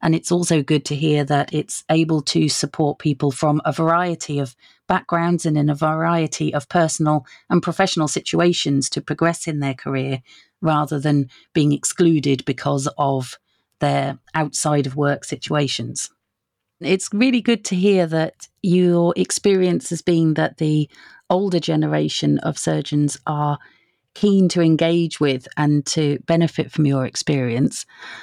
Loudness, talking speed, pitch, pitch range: -20 LUFS, 145 wpm, 155 Hz, 145-170 Hz